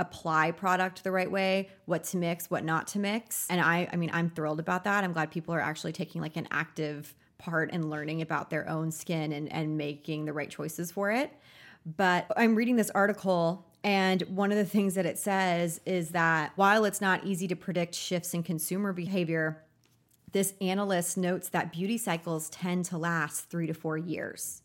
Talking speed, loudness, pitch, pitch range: 200 wpm, -30 LUFS, 175 Hz, 160-190 Hz